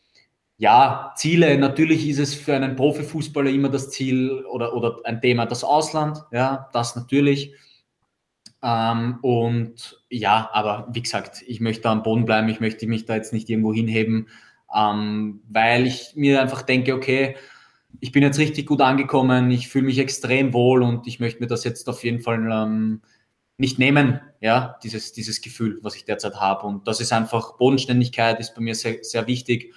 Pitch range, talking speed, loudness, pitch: 115-135 Hz, 175 wpm, -21 LUFS, 120 Hz